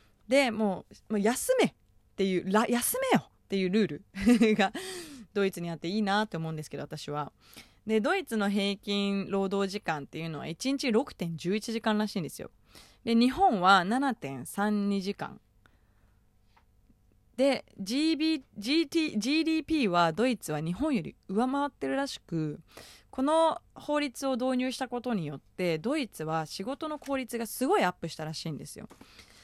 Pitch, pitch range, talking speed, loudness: 210 Hz, 170-260 Hz, 265 characters per minute, -30 LUFS